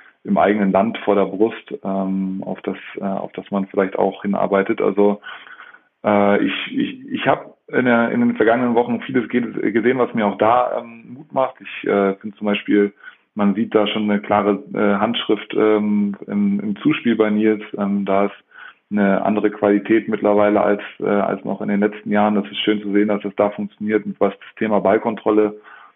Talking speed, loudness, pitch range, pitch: 195 wpm, -19 LUFS, 100-110 Hz, 105 Hz